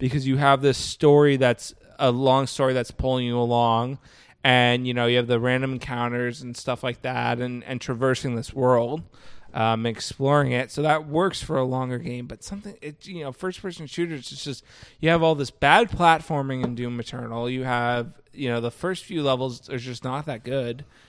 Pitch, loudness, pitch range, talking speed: 130 Hz, -23 LUFS, 120-145 Hz, 205 wpm